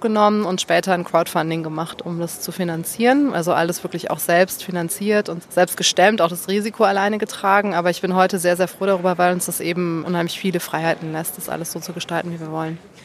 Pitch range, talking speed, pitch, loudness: 170-195 Hz, 220 wpm, 175 Hz, -20 LUFS